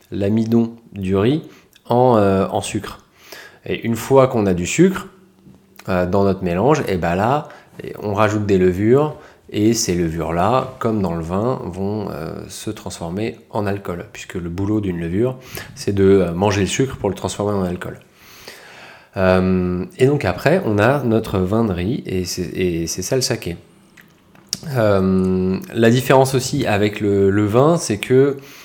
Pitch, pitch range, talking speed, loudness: 105 Hz, 95-125 Hz, 170 wpm, -18 LUFS